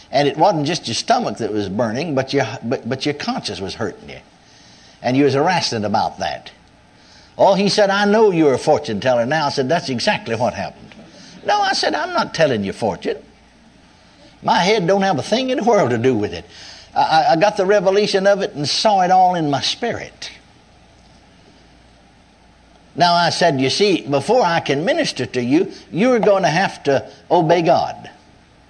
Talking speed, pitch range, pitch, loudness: 195 wpm, 130-200 Hz, 165 Hz, -17 LUFS